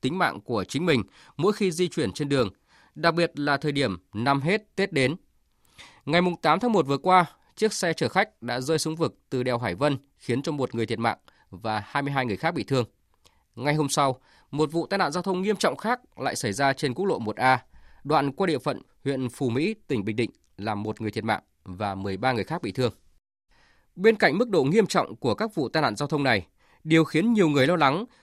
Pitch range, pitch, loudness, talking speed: 115-170 Hz, 140 Hz, -25 LUFS, 235 wpm